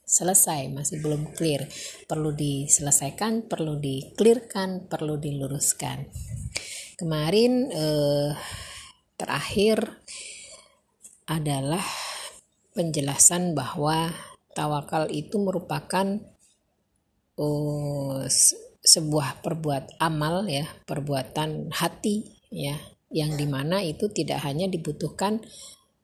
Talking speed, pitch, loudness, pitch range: 75 wpm, 155 Hz, -25 LUFS, 145-185 Hz